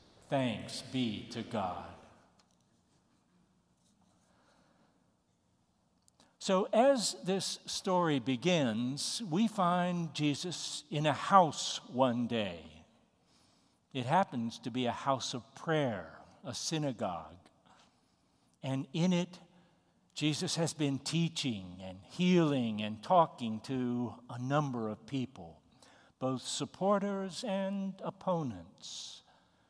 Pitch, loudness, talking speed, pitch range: 145 Hz, -34 LUFS, 95 wpm, 120-180 Hz